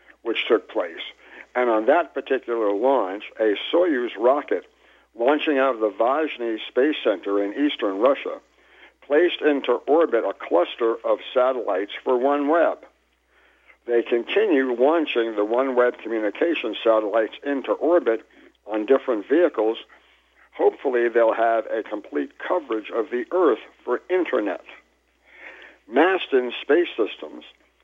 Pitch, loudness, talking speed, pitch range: 130 Hz, -22 LUFS, 120 wpm, 115-175 Hz